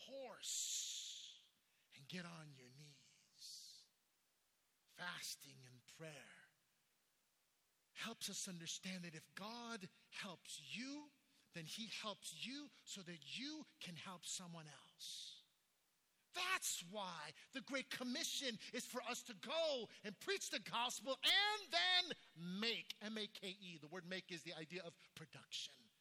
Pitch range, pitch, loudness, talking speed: 170-255 Hz, 205 Hz, -46 LUFS, 125 wpm